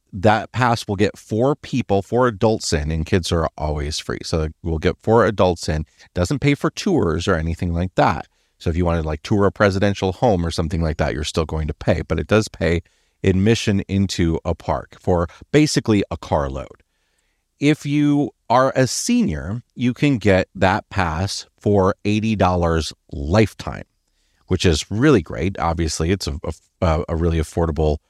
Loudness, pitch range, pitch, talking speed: -20 LUFS, 80-110 Hz, 95 Hz, 180 wpm